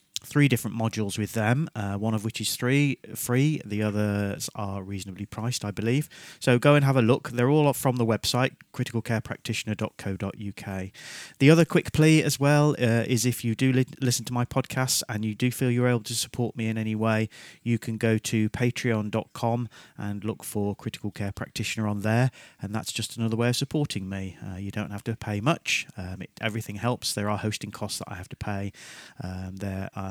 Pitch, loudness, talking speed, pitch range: 115 Hz, -26 LUFS, 205 wpm, 105-125 Hz